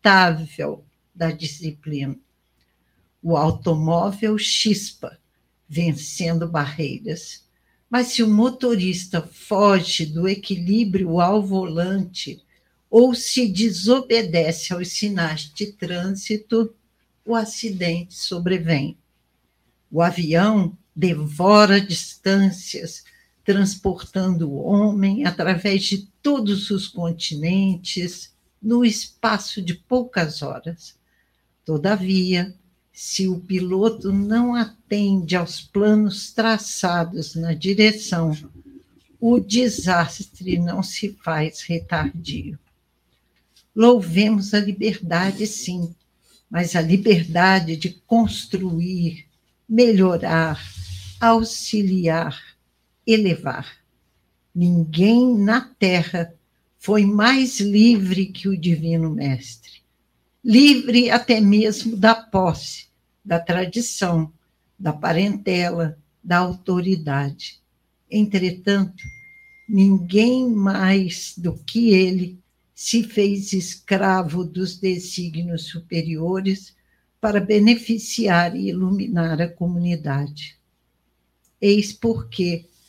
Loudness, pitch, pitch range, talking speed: -20 LUFS, 185 Hz, 165-210 Hz, 80 wpm